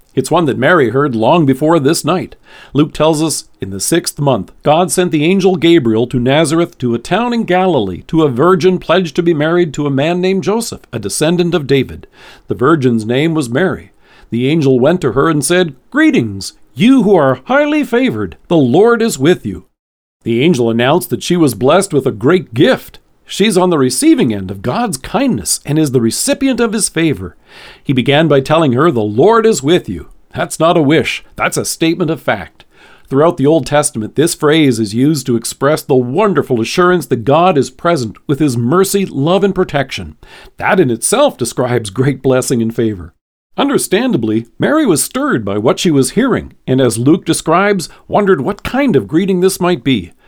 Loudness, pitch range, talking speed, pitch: -12 LUFS, 125-180 Hz, 195 wpm, 155 Hz